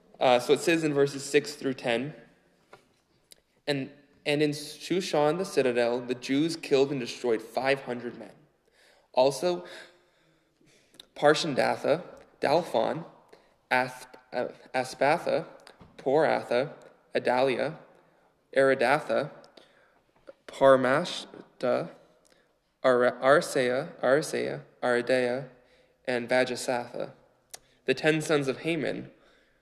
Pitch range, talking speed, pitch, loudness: 125-150 Hz, 85 wpm, 135 Hz, -27 LUFS